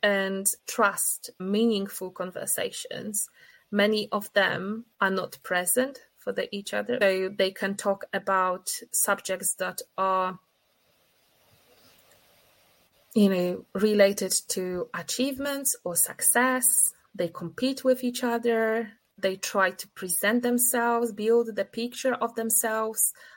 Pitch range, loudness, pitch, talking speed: 190-240 Hz, -26 LUFS, 210 Hz, 115 wpm